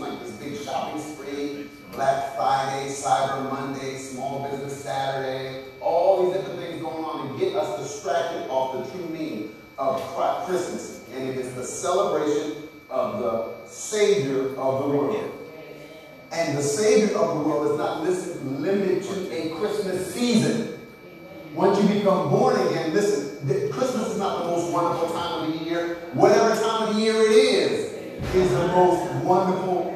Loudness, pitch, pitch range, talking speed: -24 LUFS, 170 Hz, 140-190 Hz, 150 wpm